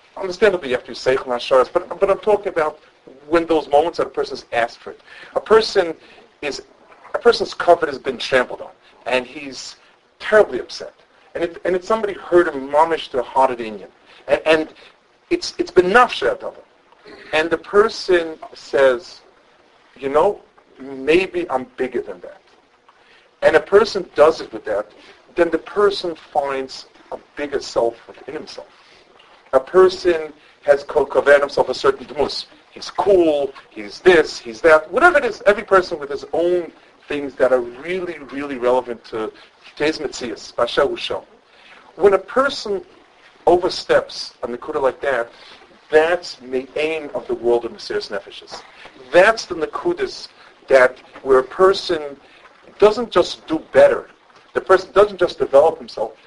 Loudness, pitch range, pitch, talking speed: -18 LUFS, 145-210 Hz, 175 Hz, 155 wpm